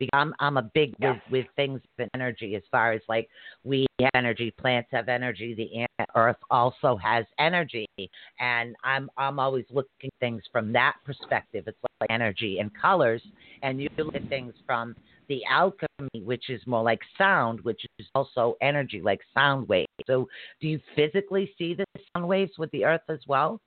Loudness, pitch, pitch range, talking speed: -27 LUFS, 130 Hz, 115-145 Hz, 185 wpm